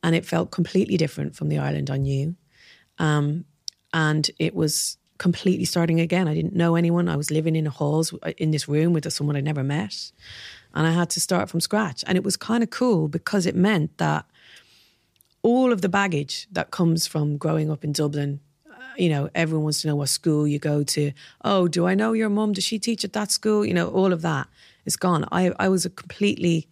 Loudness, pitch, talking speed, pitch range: -23 LUFS, 165 Hz, 220 wpm, 150-185 Hz